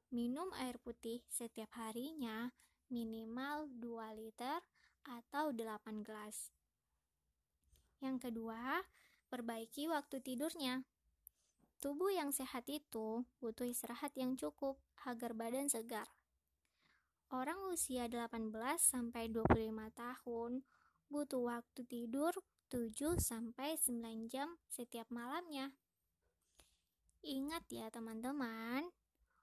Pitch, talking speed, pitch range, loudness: 245 Hz, 90 wpm, 230-280 Hz, -44 LUFS